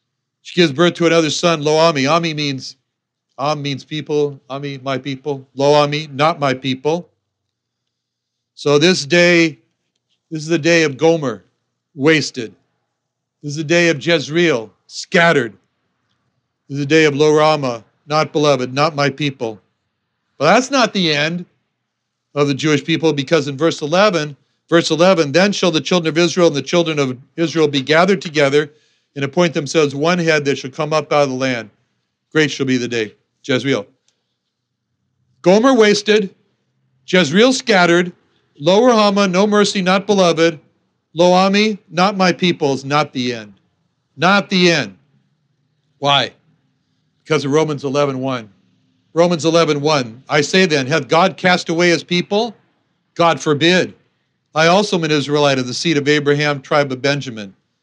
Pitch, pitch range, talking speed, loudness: 155 Hz, 140-170 Hz, 155 wpm, -15 LUFS